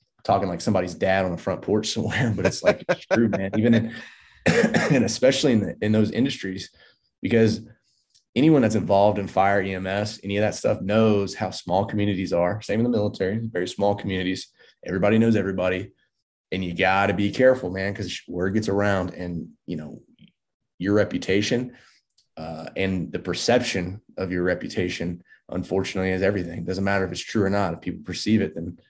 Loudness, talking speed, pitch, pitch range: -23 LUFS, 185 wpm, 100 Hz, 95-105 Hz